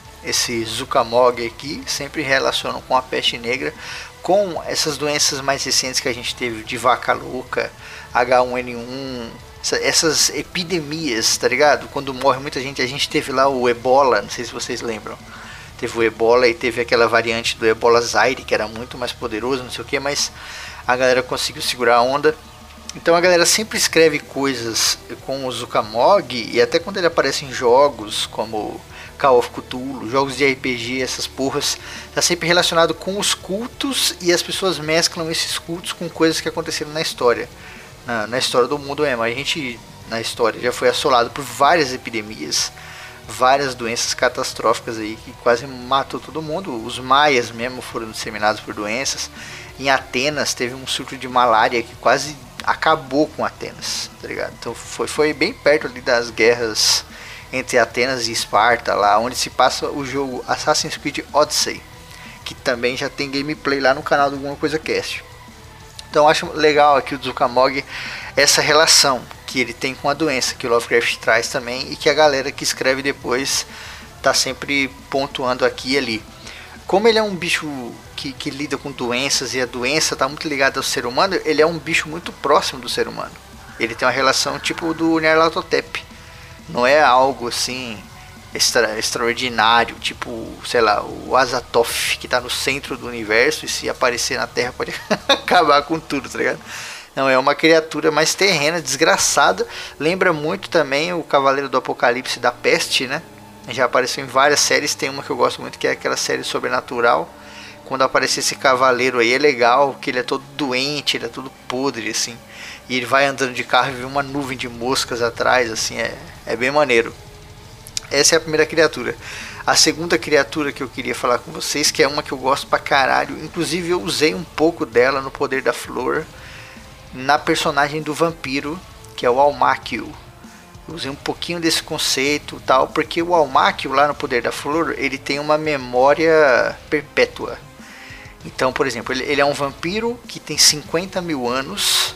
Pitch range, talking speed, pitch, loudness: 125-155 Hz, 180 wpm, 140 Hz, -18 LUFS